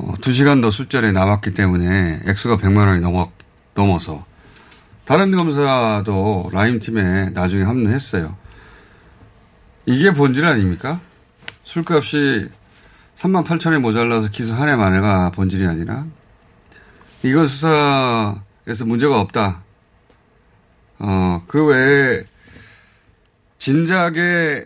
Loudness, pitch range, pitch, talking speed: -17 LUFS, 95-135 Hz, 110 Hz, 220 characters per minute